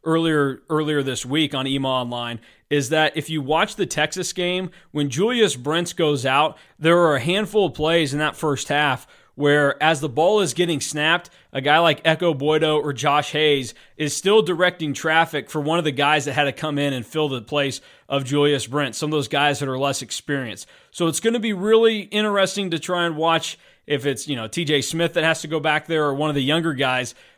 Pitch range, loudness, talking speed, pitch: 145-170 Hz, -21 LUFS, 225 wpm, 155 Hz